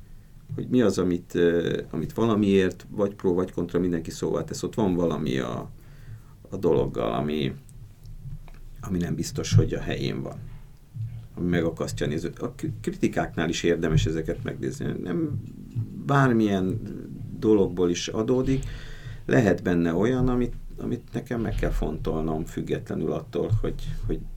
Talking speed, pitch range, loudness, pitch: 135 wpm, 85-125 Hz, -26 LUFS, 110 Hz